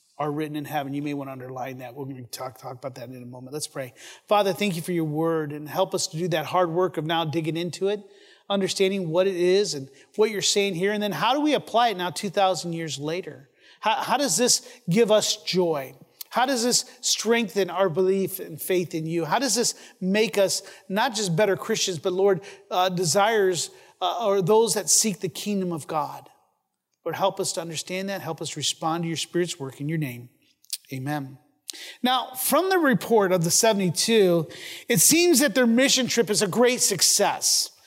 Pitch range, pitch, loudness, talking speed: 160-210 Hz, 185 Hz, -23 LUFS, 210 wpm